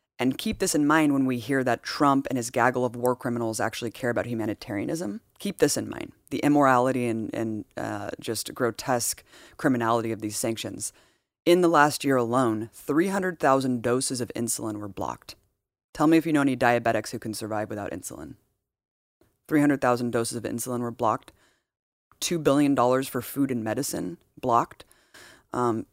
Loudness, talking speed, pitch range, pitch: -26 LUFS, 165 wpm, 115-140 Hz, 125 Hz